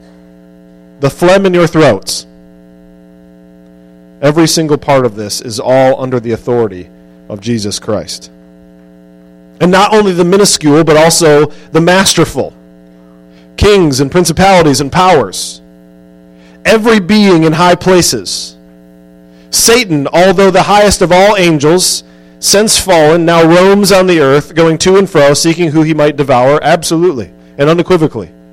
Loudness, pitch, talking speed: -8 LUFS, 145 Hz, 135 wpm